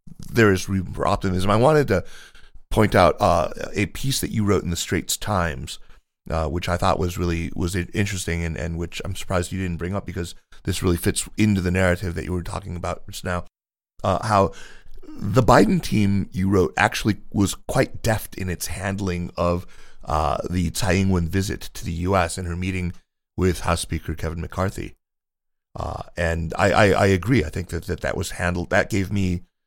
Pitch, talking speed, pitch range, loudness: 95 Hz, 200 wpm, 85-100 Hz, -23 LUFS